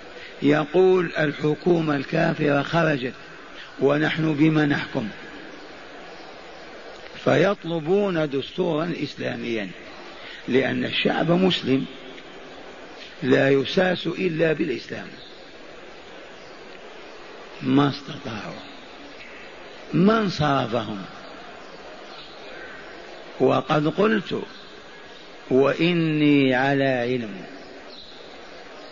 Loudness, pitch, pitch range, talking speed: -22 LUFS, 155 Hz, 135-170 Hz, 55 wpm